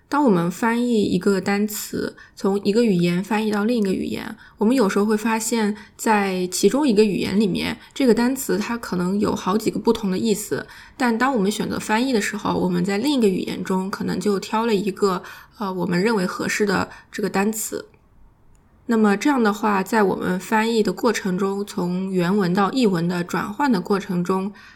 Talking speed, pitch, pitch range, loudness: 295 characters per minute, 205 Hz, 195-225 Hz, -21 LUFS